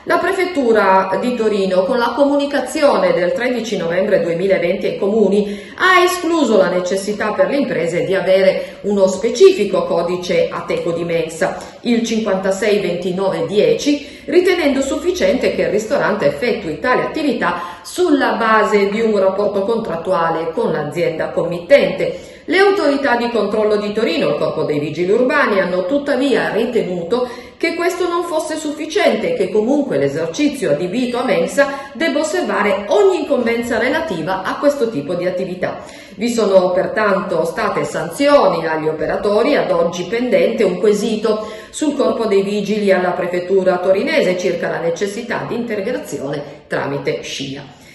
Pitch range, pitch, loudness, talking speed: 190-280 Hz, 215 Hz, -16 LUFS, 140 wpm